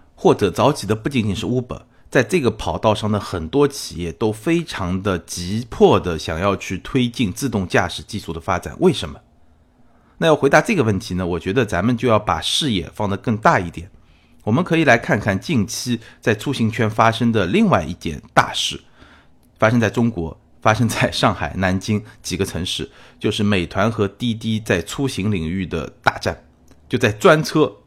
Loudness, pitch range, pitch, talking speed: -19 LUFS, 90-120 Hz, 105 Hz, 280 characters per minute